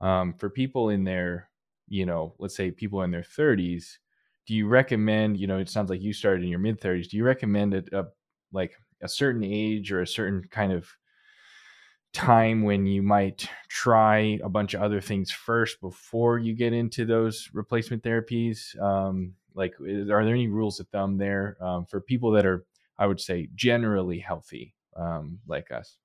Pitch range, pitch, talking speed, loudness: 95-115 Hz, 105 Hz, 190 wpm, -26 LUFS